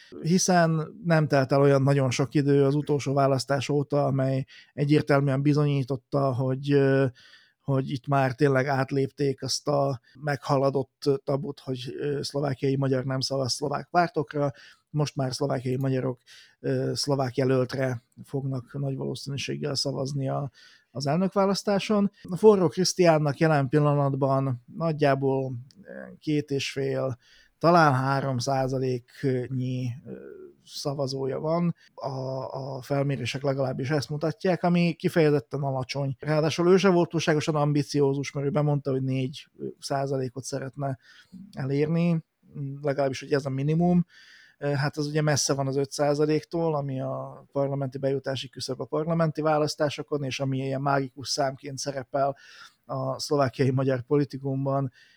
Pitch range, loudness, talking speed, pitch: 135-150 Hz, -26 LUFS, 120 wpm, 140 Hz